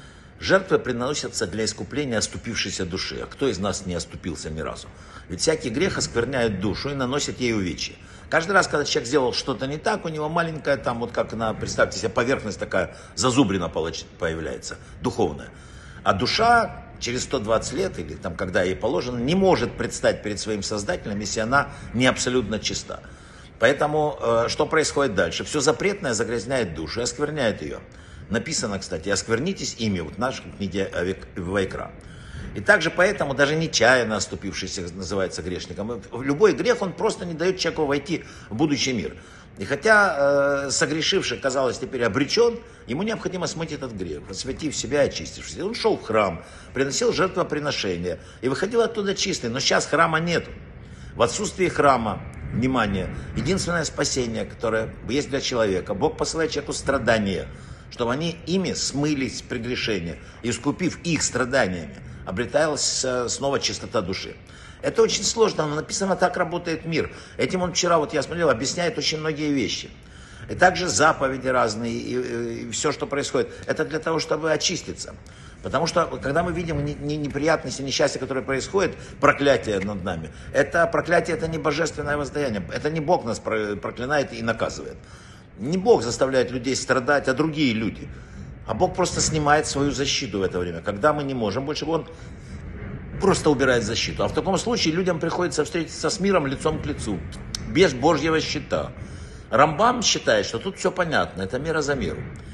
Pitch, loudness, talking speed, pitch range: 140 Hz, -23 LUFS, 160 wpm, 110-160 Hz